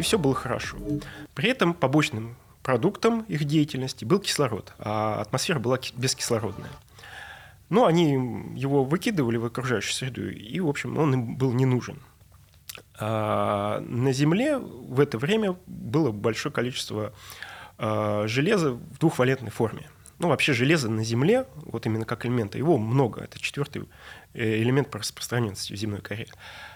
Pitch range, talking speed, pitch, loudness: 110-150 Hz, 140 wpm, 130 Hz, -26 LUFS